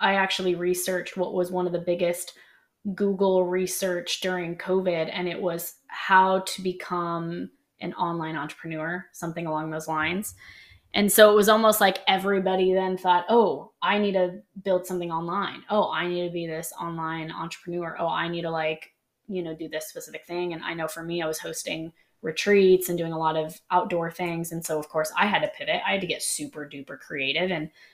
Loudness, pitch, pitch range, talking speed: -25 LUFS, 175 Hz, 165-190 Hz, 200 wpm